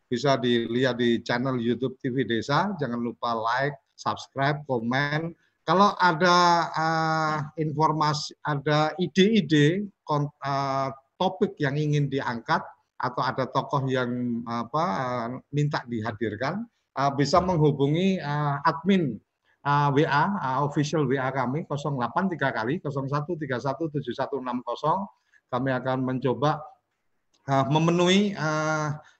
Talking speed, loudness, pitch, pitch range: 105 wpm, -25 LUFS, 145 Hz, 130-160 Hz